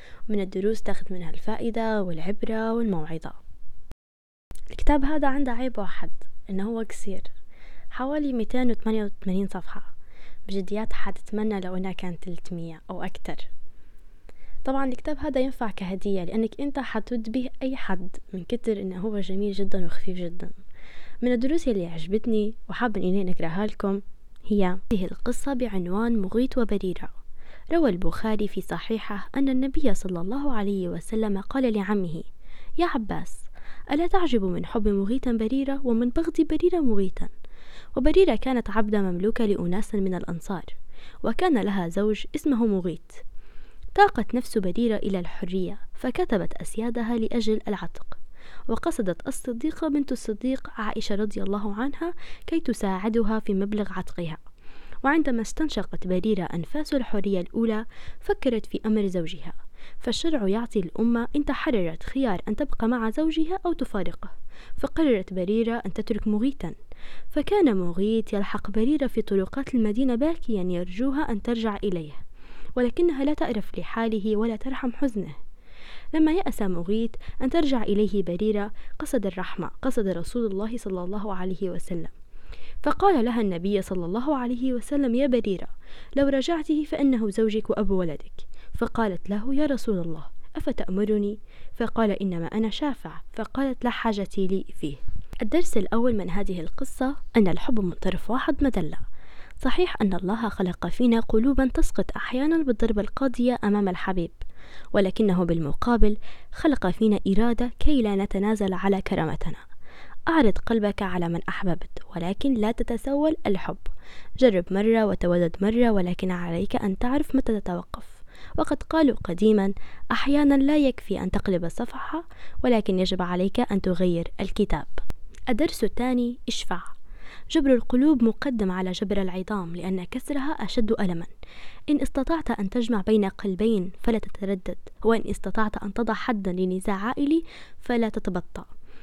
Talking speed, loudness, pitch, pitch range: 130 wpm, -26 LUFS, 220 Hz, 195-255 Hz